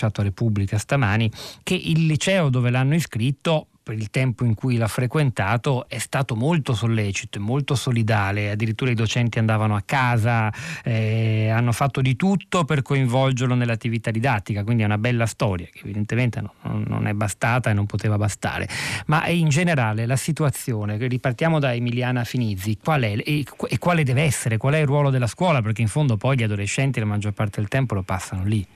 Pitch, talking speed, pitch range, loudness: 120 Hz, 185 wpm, 110-140 Hz, -22 LUFS